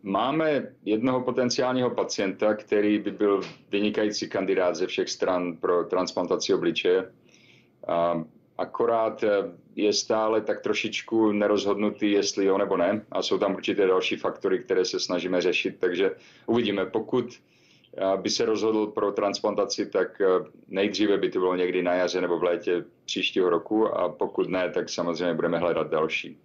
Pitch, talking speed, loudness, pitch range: 110 Hz, 145 wpm, -26 LUFS, 100-130 Hz